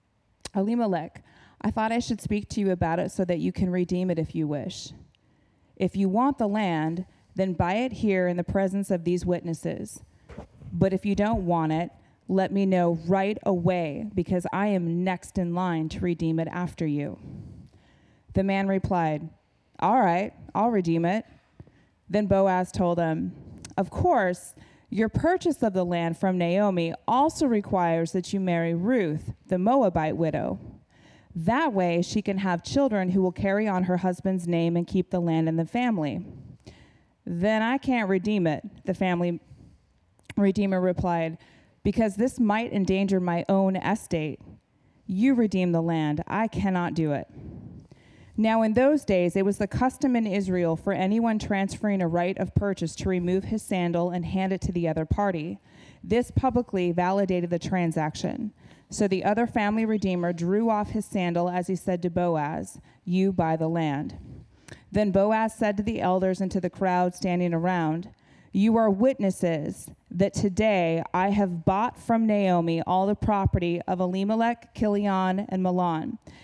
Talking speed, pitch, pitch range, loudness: 165 wpm, 185 Hz, 170-205 Hz, -26 LUFS